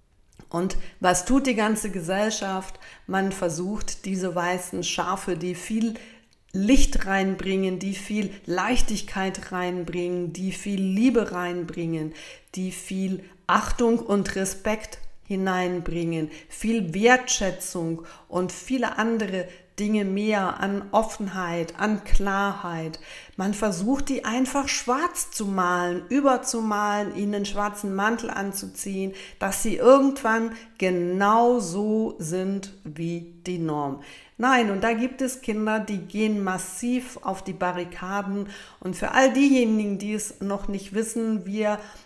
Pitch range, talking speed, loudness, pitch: 185-220 Hz, 120 wpm, -25 LUFS, 195 Hz